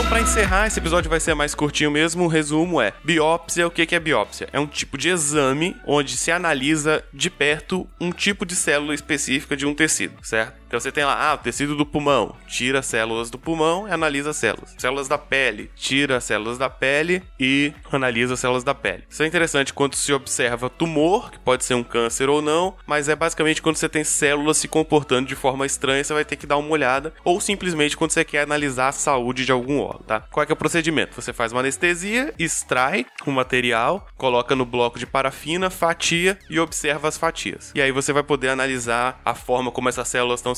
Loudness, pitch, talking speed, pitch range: -21 LUFS, 145 Hz, 225 wpm, 130-160 Hz